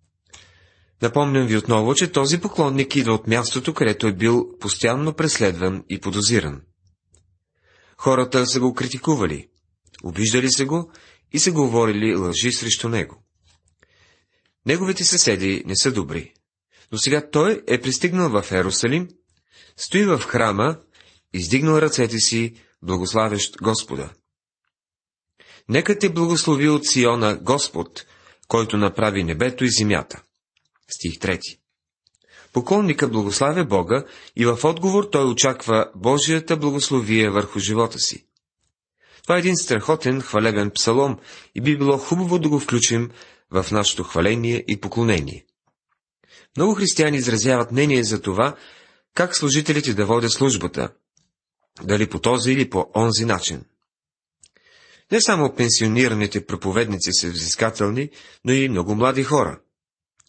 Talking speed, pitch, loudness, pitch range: 120 wpm, 115 Hz, -20 LUFS, 100-140 Hz